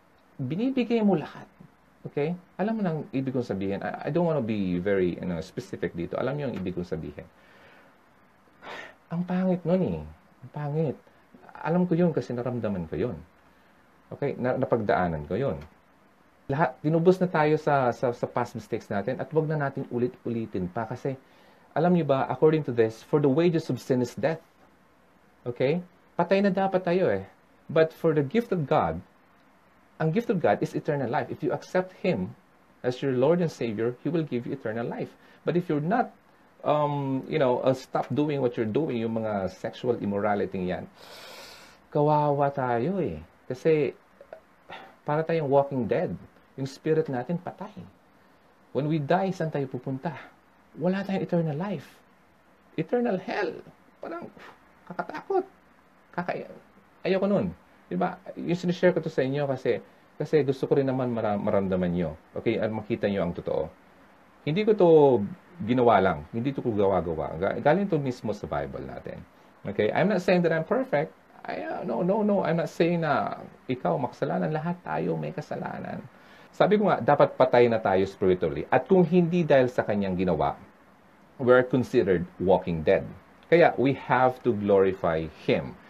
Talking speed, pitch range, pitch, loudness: 165 wpm, 115-170 Hz, 140 Hz, -27 LUFS